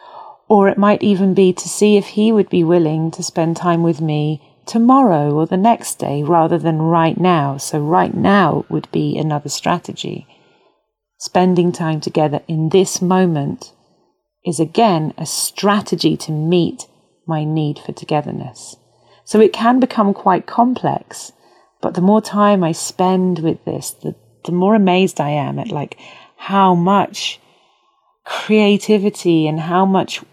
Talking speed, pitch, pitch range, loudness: 150 wpm, 175 Hz, 160-200 Hz, -15 LUFS